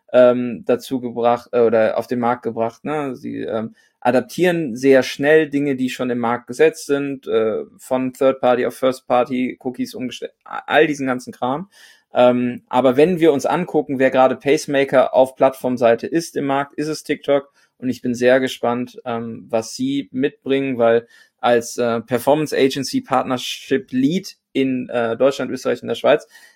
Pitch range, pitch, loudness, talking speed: 125-145 Hz, 130 Hz, -19 LUFS, 160 wpm